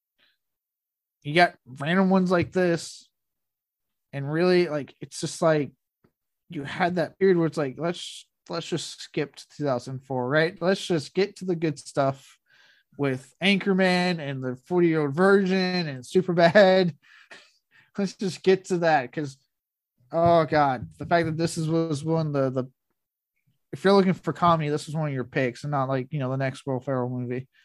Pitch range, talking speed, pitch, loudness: 135-180 Hz, 180 wpm, 160 Hz, -25 LUFS